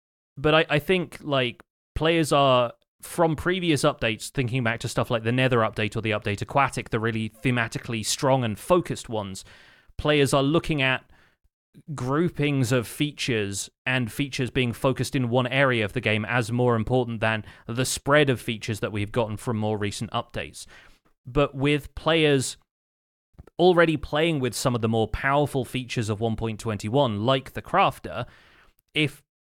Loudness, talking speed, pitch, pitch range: -24 LUFS, 160 wpm, 125 Hz, 110-145 Hz